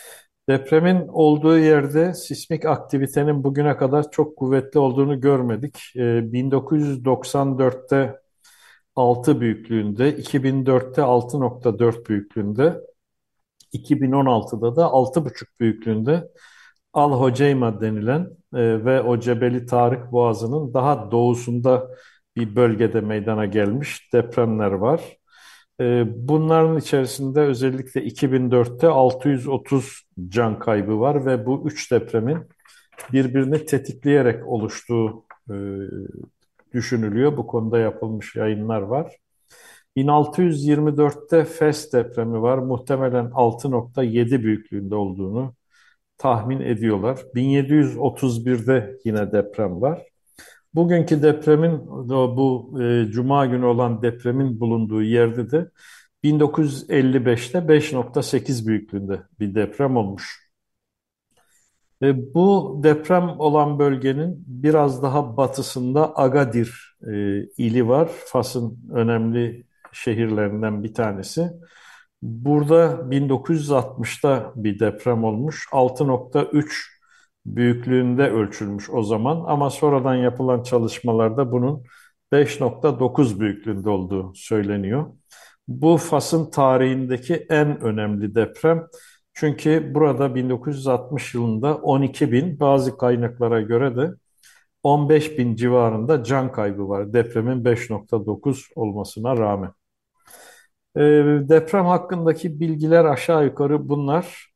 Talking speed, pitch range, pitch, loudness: 90 wpm, 115-150 Hz, 130 Hz, -20 LUFS